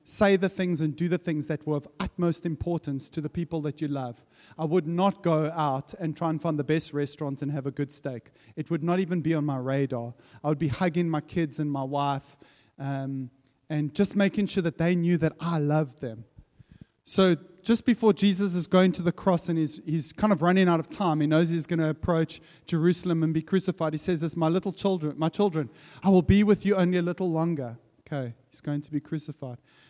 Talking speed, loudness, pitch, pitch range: 235 wpm, -27 LUFS, 160 Hz, 145-175 Hz